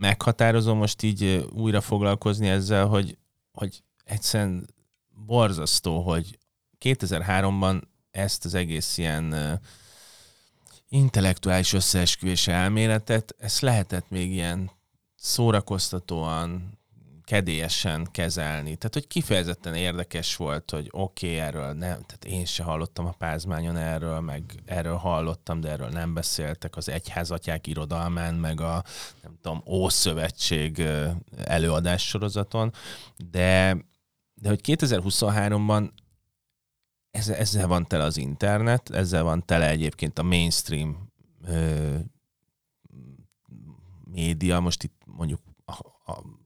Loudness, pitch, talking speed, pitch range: -26 LUFS, 90 Hz, 105 wpm, 80-105 Hz